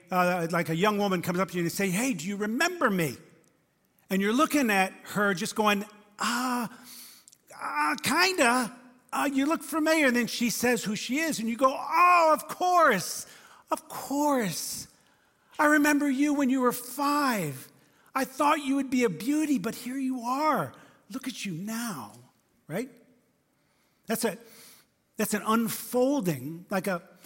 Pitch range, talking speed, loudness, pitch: 200-275 Hz, 170 wpm, -27 LUFS, 240 Hz